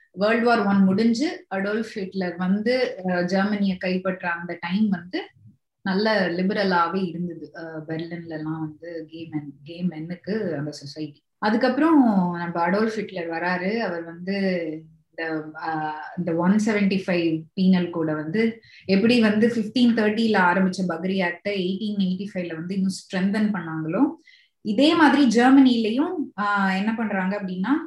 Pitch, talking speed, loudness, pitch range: 190 Hz, 120 wpm, -23 LUFS, 170-215 Hz